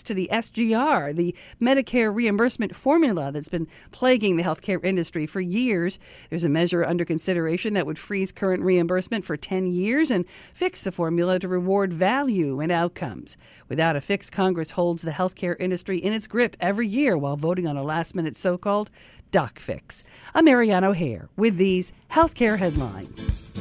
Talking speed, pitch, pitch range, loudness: 180 wpm, 185 Hz, 170-215 Hz, -24 LUFS